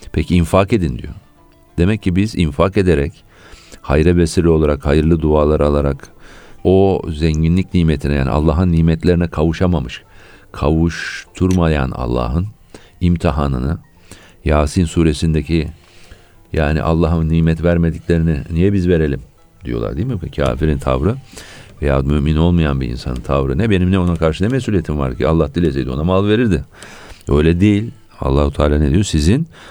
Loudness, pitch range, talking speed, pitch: -16 LUFS, 75-90 Hz, 135 wpm, 80 Hz